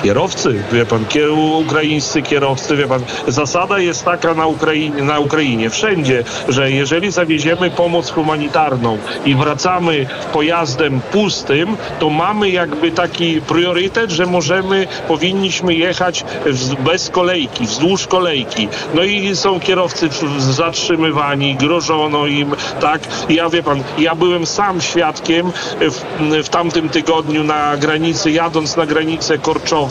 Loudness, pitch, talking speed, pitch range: -15 LUFS, 160 Hz, 130 wpm, 150-175 Hz